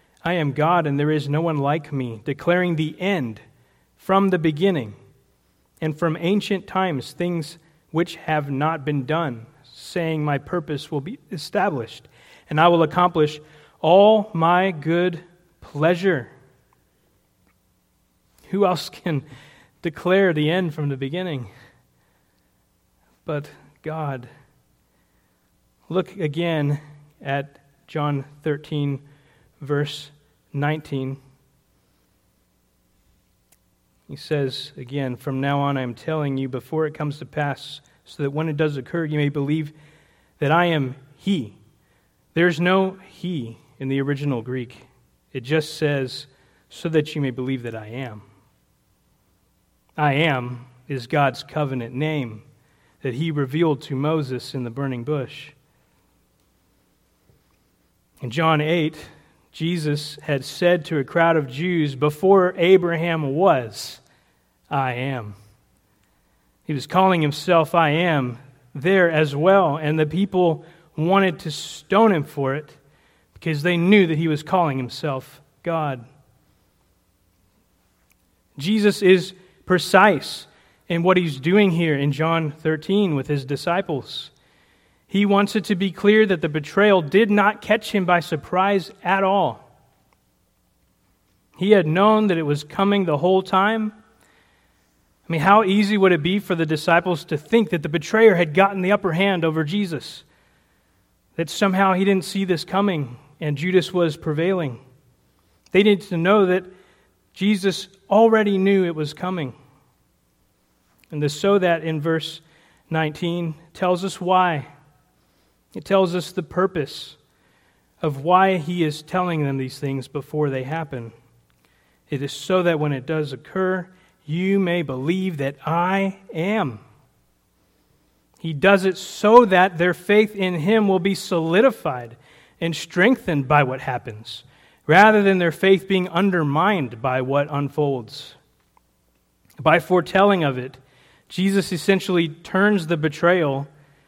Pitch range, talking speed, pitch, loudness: 140-180 Hz, 135 wpm, 155 Hz, -21 LUFS